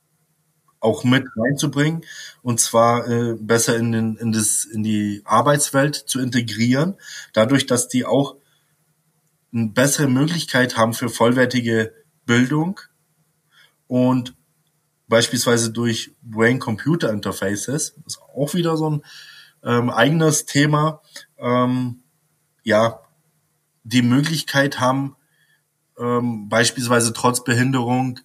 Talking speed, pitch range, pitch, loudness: 110 wpm, 120-150 Hz, 130 Hz, -19 LUFS